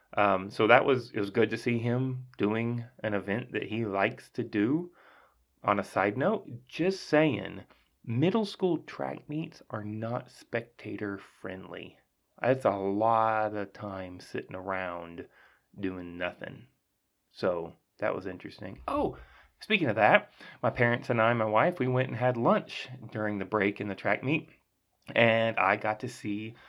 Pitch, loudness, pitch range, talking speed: 110 Hz, -29 LUFS, 100-125 Hz, 165 wpm